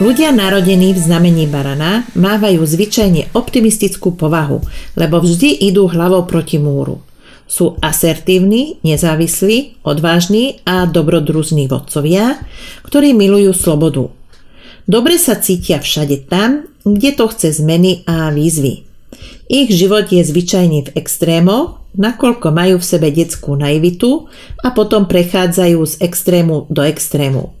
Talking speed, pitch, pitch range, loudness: 120 wpm, 180 Hz, 160-210 Hz, -12 LUFS